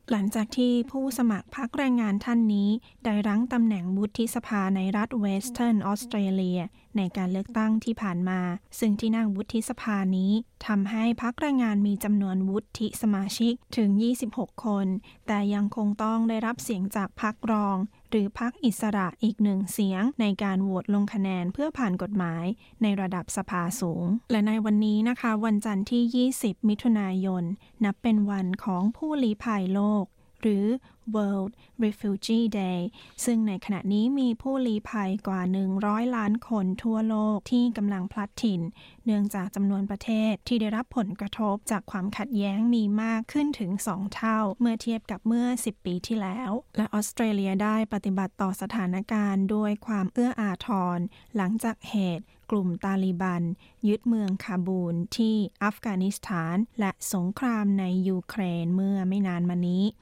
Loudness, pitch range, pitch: -27 LUFS, 195-225 Hz, 210 Hz